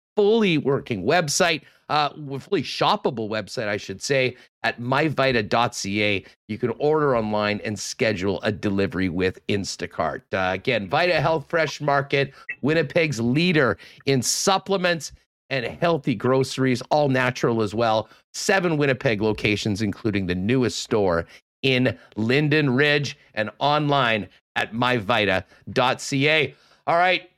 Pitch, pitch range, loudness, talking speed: 130 Hz, 110-150 Hz, -22 LUFS, 120 wpm